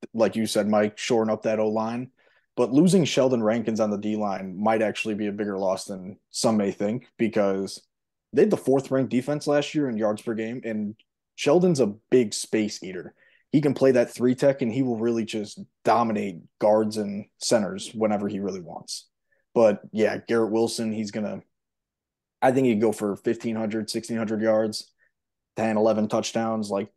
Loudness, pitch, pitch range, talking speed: -24 LUFS, 110 Hz, 105-120 Hz, 185 wpm